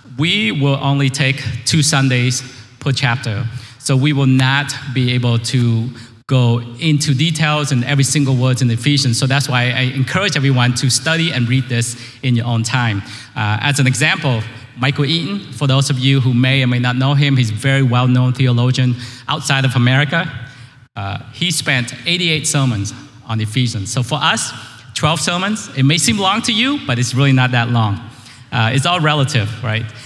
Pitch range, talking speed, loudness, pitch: 120-145 Hz, 195 wpm, -15 LUFS, 130 Hz